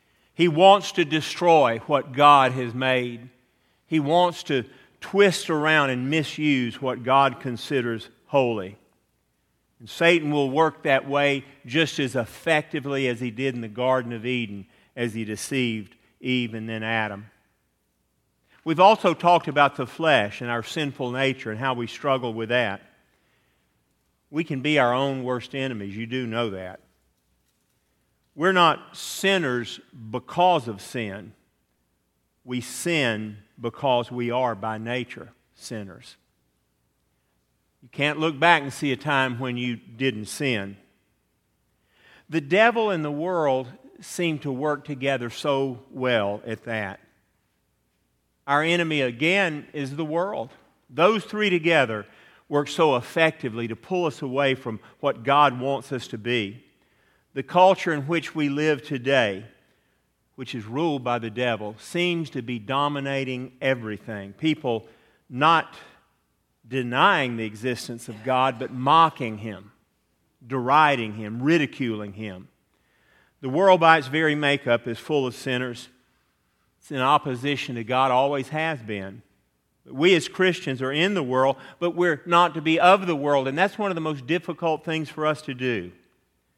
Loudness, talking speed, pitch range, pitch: -23 LUFS, 145 wpm, 115-150 Hz, 130 Hz